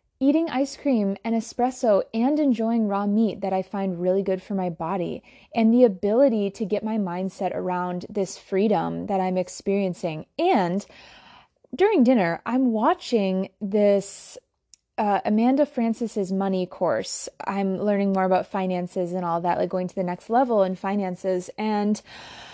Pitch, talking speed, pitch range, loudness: 200 Hz, 155 wpm, 185-230 Hz, -24 LUFS